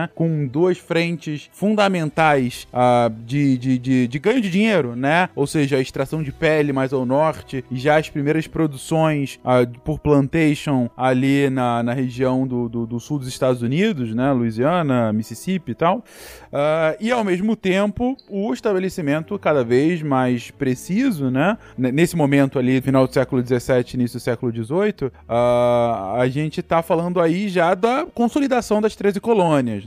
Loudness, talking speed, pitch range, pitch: -20 LUFS, 165 wpm, 125-175 Hz, 145 Hz